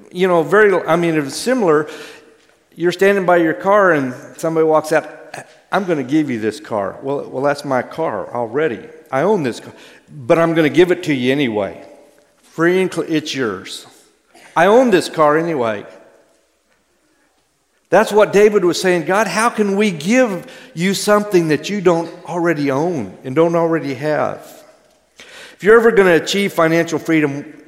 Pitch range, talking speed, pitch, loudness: 155-200 Hz, 190 wpm, 170 Hz, -16 LUFS